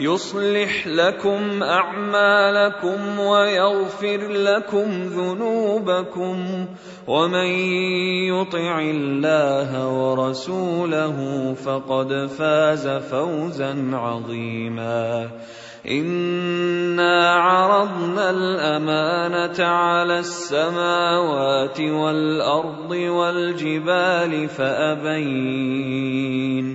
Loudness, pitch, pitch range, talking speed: -20 LUFS, 175 Hz, 140-185 Hz, 50 wpm